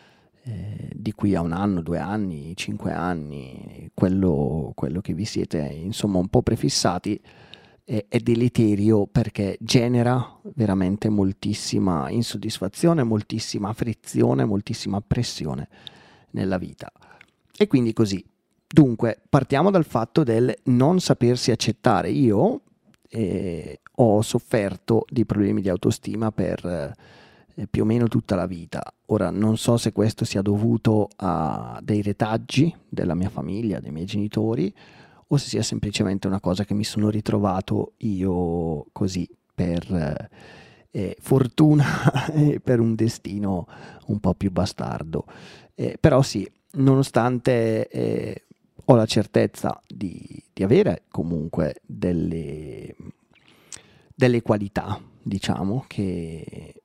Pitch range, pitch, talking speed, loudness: 95-120 Hz, 105 Hz, 120 wpm, -23 LUFS